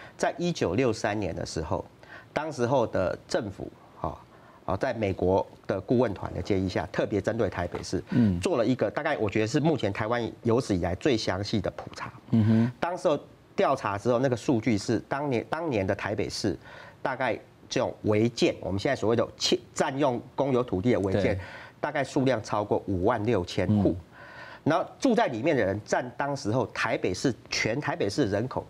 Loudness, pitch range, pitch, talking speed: -28 LUFS, 105-130 Hz, 115 Hz, 285 characters per minute